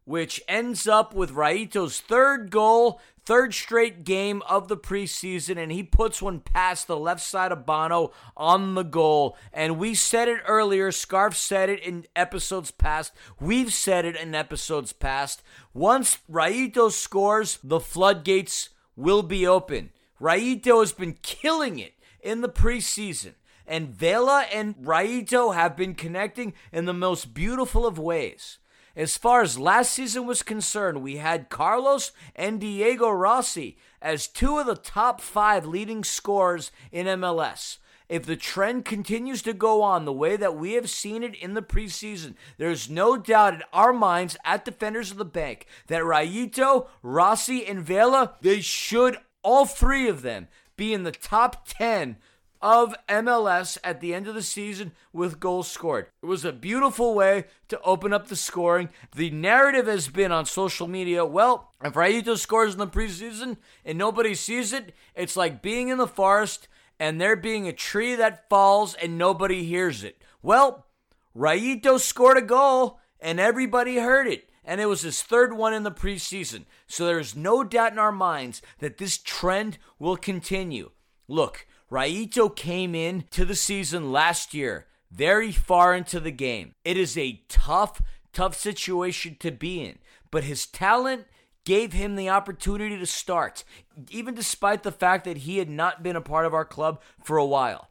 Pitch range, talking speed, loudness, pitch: 170-225 Hz, 170 wpm, -24 LUFS, 195 Hz